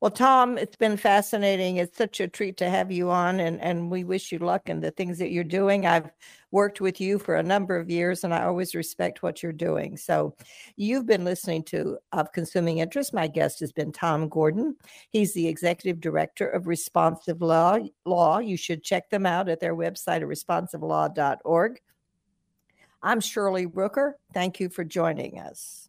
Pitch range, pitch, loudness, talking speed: 170-200 Hz, 180 Hz, -26 LUFS, 190 wpm